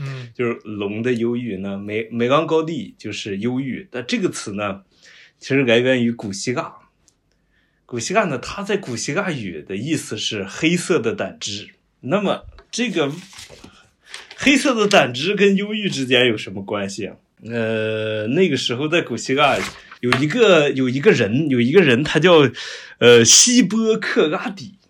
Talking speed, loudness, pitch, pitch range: 235 characters per minute, -18 LUFS, 125 Hz, 115-170 Hz